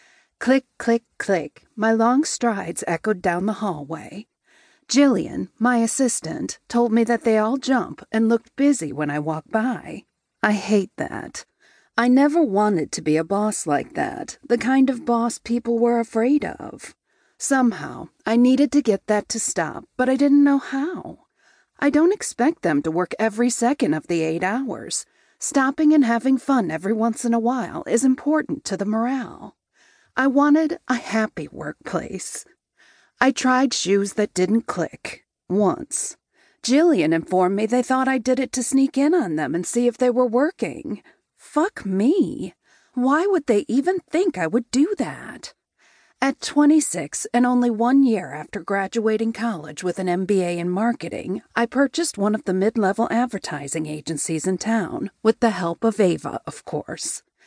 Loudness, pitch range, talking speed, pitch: -21 LUFS, 200-270 Hz, 165 wpm, 235 Hz